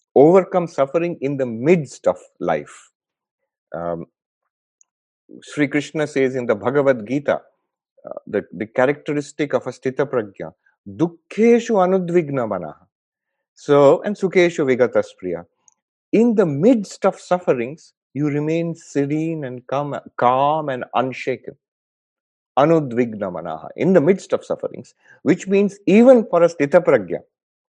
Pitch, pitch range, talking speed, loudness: 160 Hz, 135-190 Hz, 120 wpm, -19 LUFS